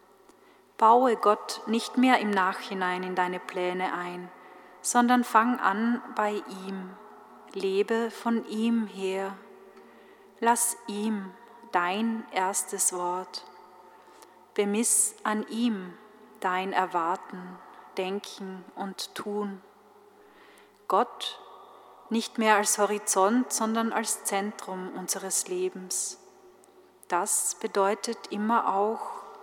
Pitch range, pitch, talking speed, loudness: 185-225 Hz, 205 Hz, 95 wpm, -27 LUFS